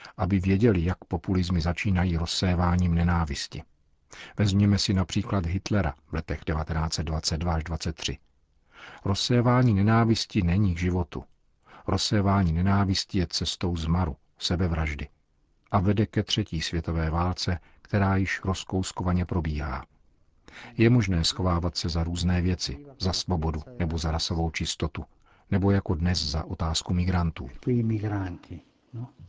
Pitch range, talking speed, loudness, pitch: 80-100 Hz, 115 wpm, -26 LUFS, 90 Hz